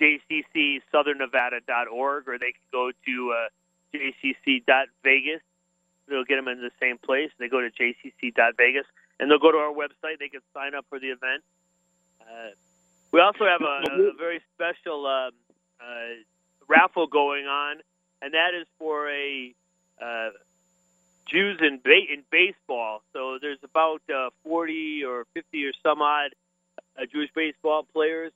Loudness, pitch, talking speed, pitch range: -24 LUFS, 145 Hz, 150 wpm, 130-170 Hz